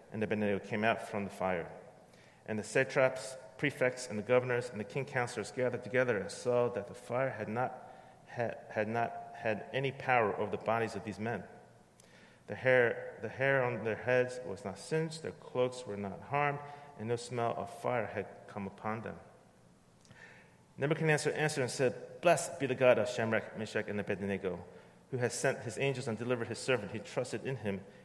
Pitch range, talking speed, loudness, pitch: 105-130 Hz, 190 wpm, -34 LUFS, 120 Hz